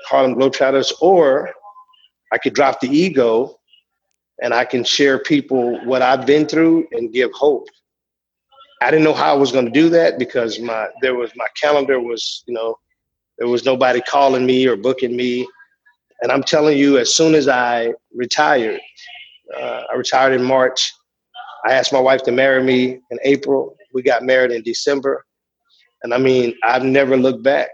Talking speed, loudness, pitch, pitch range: 175 wpm, -16 LUFS, 135 Hz, 125-170 Hz